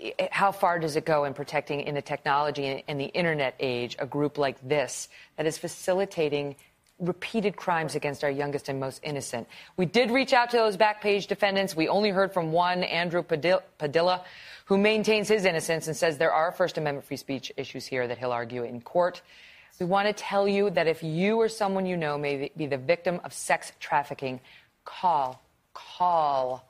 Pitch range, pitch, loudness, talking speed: 145-190 Hz, 165 Hz, -27 LUFS, 190 wpm